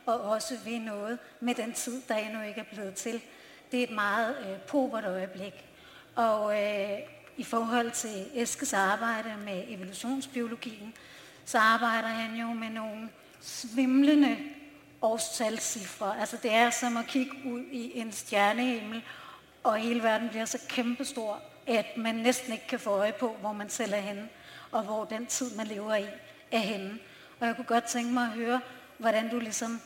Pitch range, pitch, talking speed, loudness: 215-245 Hz, 230 Hz, 175 wpm, -31 LUFS